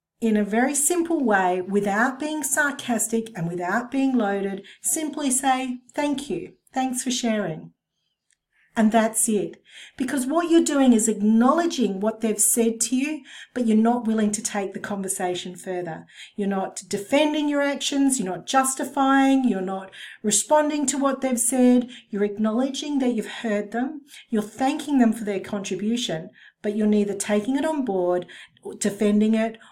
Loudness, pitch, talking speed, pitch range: -23 LUFS, 230 Hz, 155 wpm, 205-270 Hz